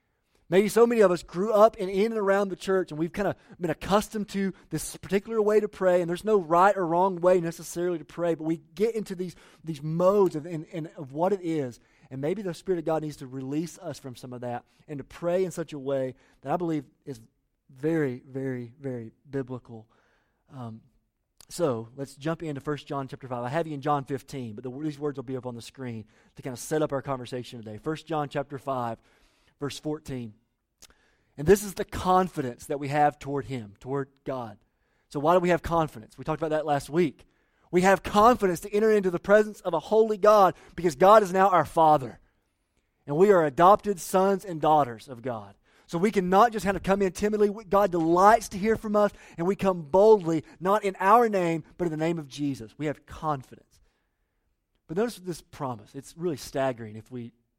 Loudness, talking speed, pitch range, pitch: -26 LUFS, 220 wpm, 135-190 Hz, 160 Hz